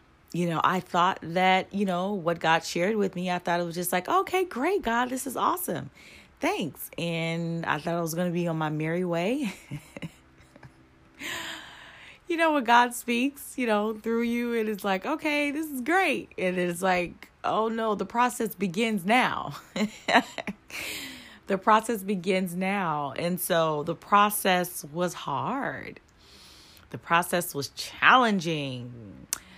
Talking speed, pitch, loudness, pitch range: 155 wpm, 185 Hz, -27 LUFS, 170-230 Hz